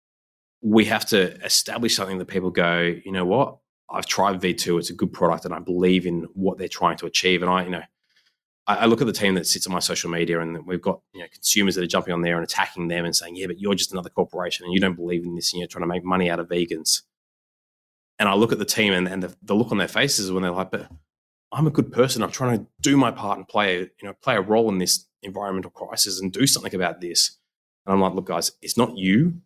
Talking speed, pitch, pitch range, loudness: 270 wpm, 95 Hz, 85-100 Hz, -22 LUFS